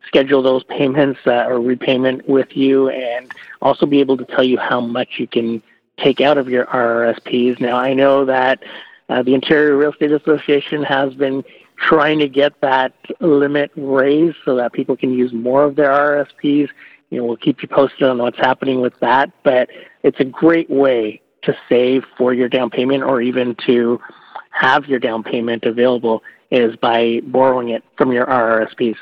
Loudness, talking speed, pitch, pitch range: -16 LUFS, 180 wpm, 130 Hz, 125-140 Hz